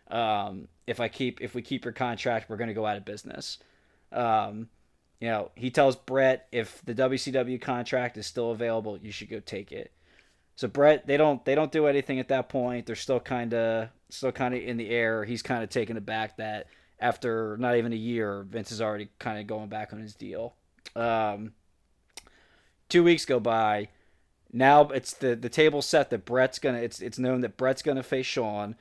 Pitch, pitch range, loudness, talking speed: 120 Hz, 110-130 Hz, -28 LUFS, 205 wpm